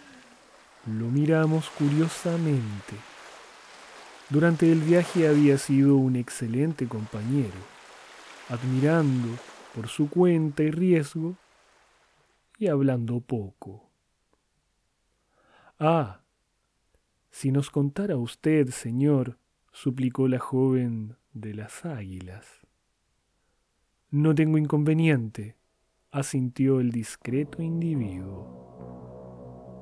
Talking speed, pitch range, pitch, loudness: 80 wpm, 115-155 Hz, 135 Hz, -25 LUFS